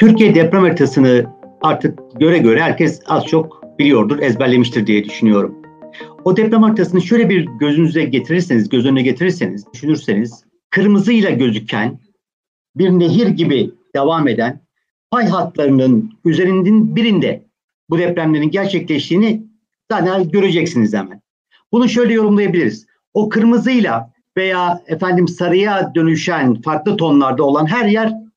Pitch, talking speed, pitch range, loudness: 170 Hz, 115 wpm, 140-205 Hz, -14 LUFS